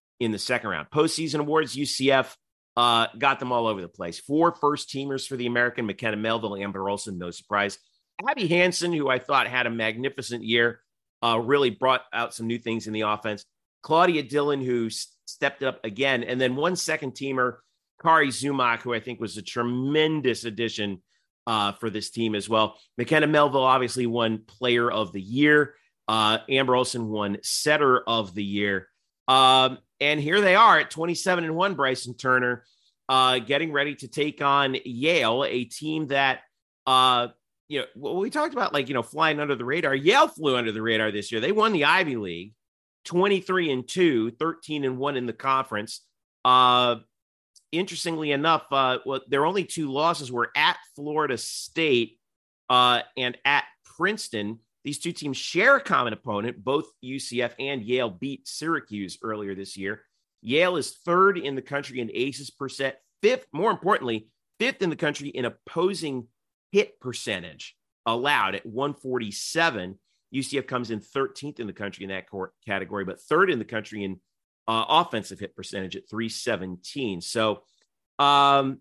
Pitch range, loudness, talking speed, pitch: 110-145 Hz, -24 LUFS, 170 wpm, 125 Hz